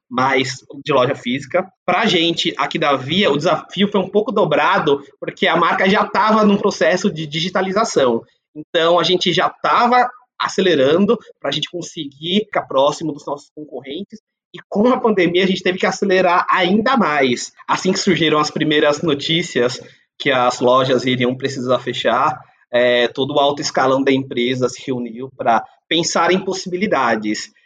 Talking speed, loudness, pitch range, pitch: 165 wpm, -17 LUFS, 135-190 Hz, 165 Hz